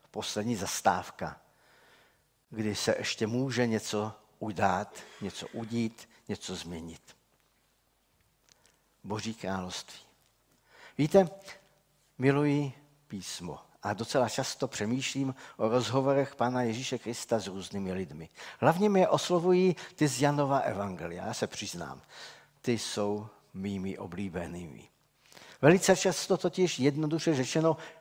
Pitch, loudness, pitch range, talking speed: 125 Hz, -30 LUFS, 105-145 Hz, 105 wpm